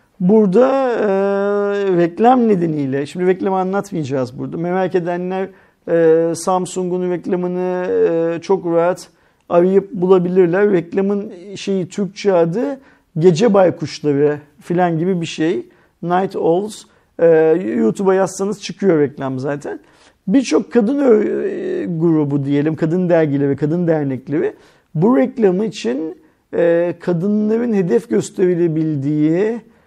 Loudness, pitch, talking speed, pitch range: -16 LUFS, 185 Hz, 105 wpm, 165-205 Hz